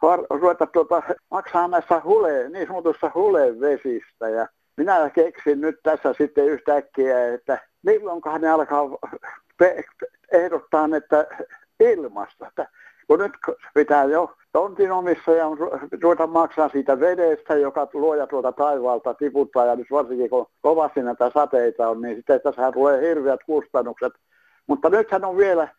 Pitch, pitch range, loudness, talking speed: 155 Hz, 140-175 Hz, -21 LUFS, 135 wpm